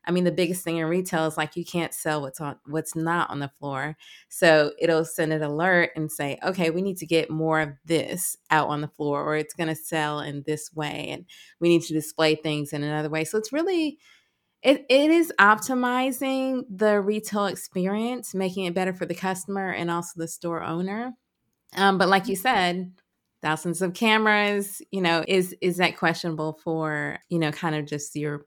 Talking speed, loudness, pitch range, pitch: 205 wpm, -25 LUFS, 155-195 Hz, 170 Hz